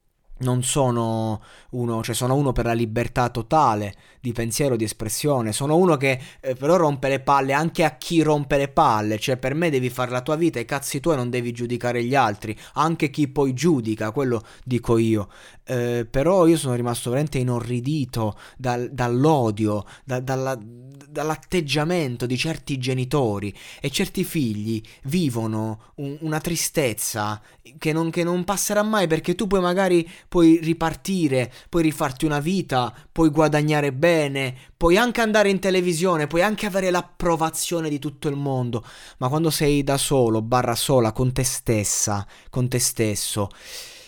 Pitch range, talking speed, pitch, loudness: 120-160 Hz, 160 wpm, 135 Hz, -22 LUFS